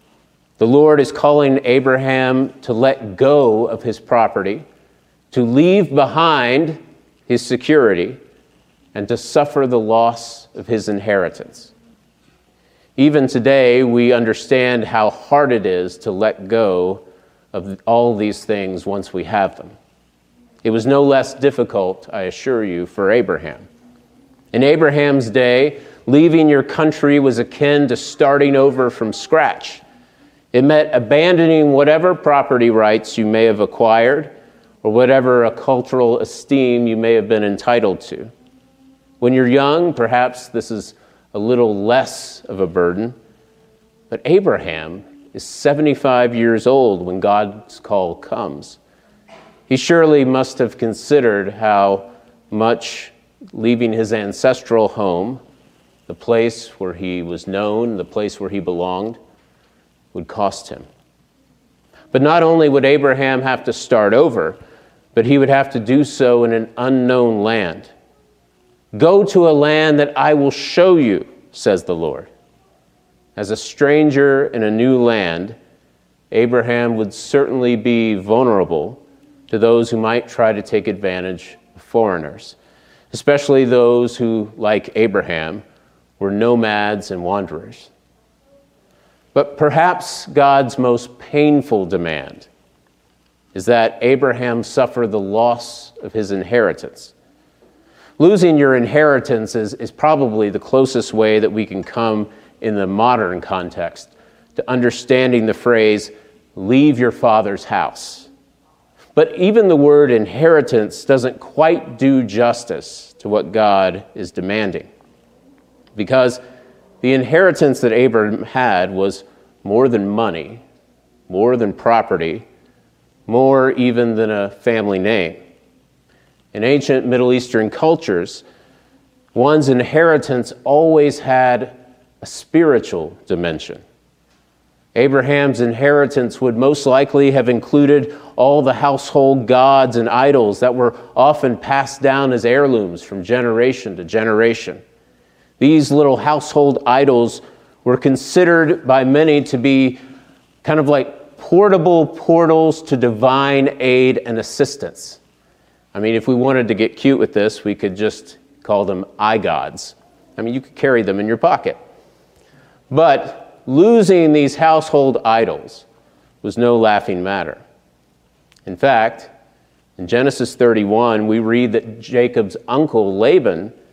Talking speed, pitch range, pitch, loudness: 130 wpm, 110-140 Hz, 120 Hz, -15 LUFS